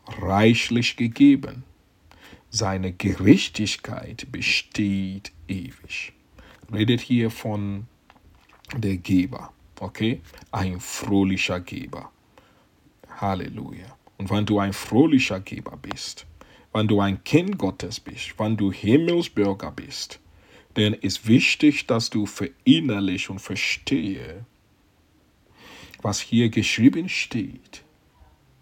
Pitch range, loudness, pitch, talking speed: 95-115 Hz, -23 LUFS, 100 Hz, 95 wpm